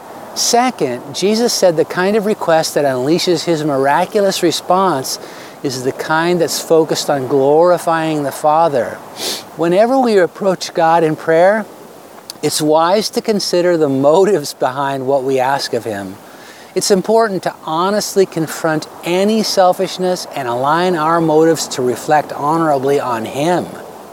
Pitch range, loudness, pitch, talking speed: 145-185 Hz, -14 LUFS, 165 Hz, 135 wpm